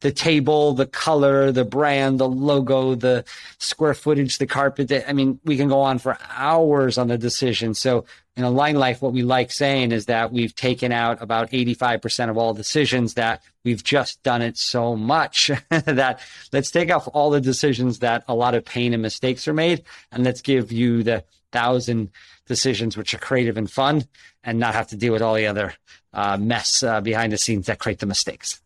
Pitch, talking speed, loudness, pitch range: 125 Hz, 205 wpm, -21 LUFS, 115-135 Hz